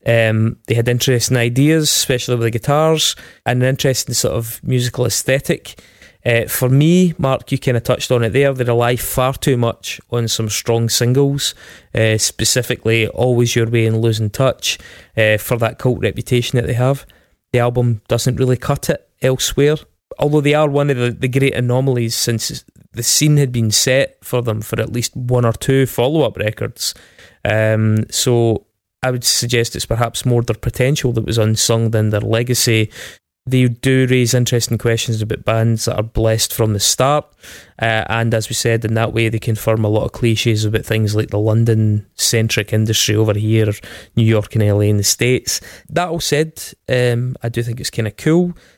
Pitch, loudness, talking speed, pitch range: 120 Hz, -16 LUFS, 190 wpm, 110-130 Hz